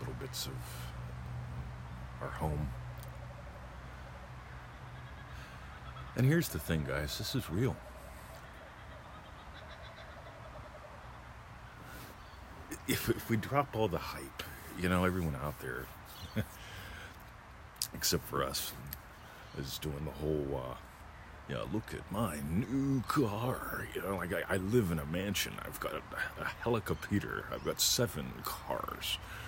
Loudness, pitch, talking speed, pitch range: -36 LUFS, 75 Hz, 120 wpm, 65-100 Hz